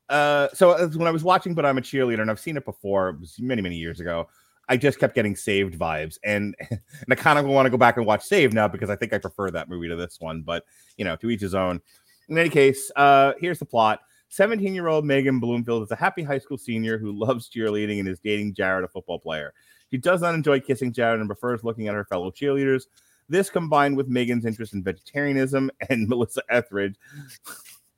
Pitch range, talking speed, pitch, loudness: 100-140 Hz, 230 wpm, 115 Hz, -23 LUFS